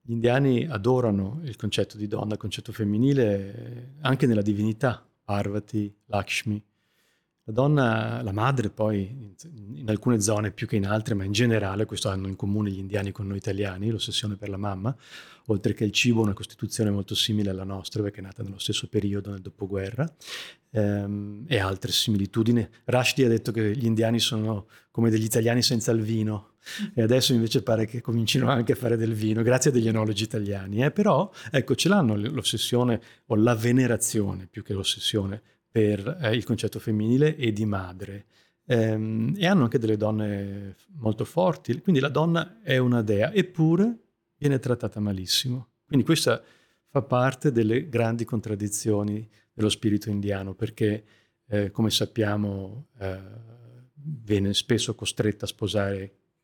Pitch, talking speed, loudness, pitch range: 110 Hz, 160 wpm, -26 LUFS, 105-125 Hz